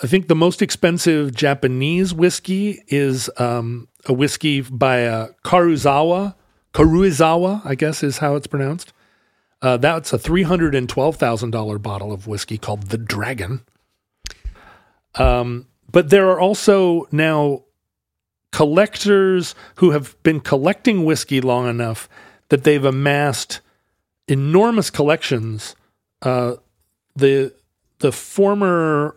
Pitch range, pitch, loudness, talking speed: 120-170 Hz, 140 Hz, -18 LUFS, 110 wpm